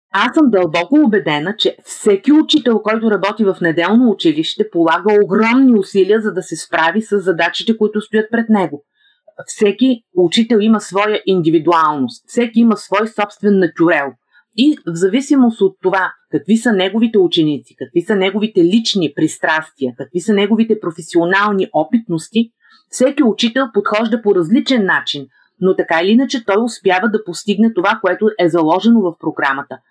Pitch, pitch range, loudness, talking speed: 205 Hz, 175-230 Hz, -14 LUFS, 150 wpm